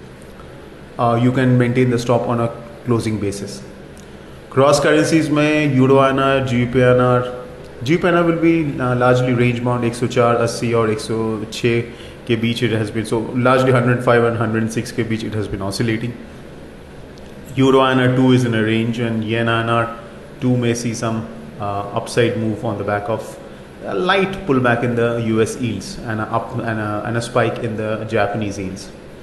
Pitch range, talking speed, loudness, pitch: 110-125 Hz, 160 wpm, -17 LUFS, 115 Hz